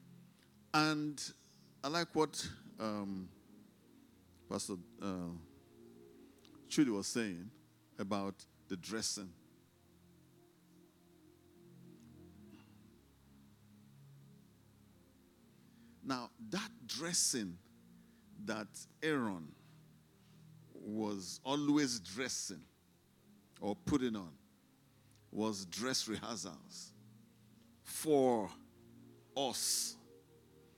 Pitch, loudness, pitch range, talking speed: 100 Hz, -39 LUFS, 85-115 Hz, 55 wpm